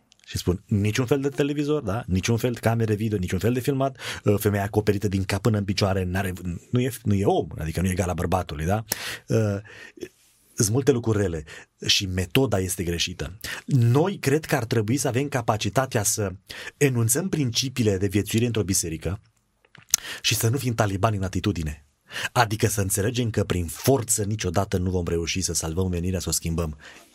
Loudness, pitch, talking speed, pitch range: -24 LUFS, 105 Hz, 180 wpm, 95-120 Hz